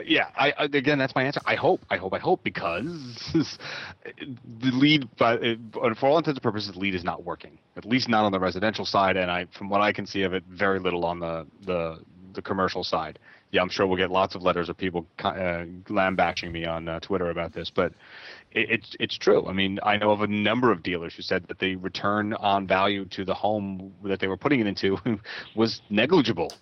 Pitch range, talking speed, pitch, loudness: 90-110 Hz, 225 wpm, 95 Hz, -25 LUFS